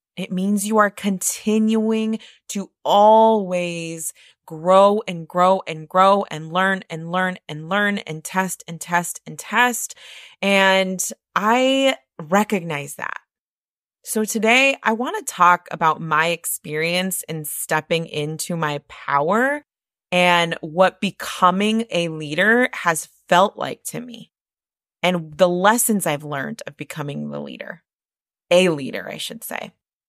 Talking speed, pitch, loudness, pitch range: 130 wpm, 180 Hz, -19 LUFS, 160-205 Hz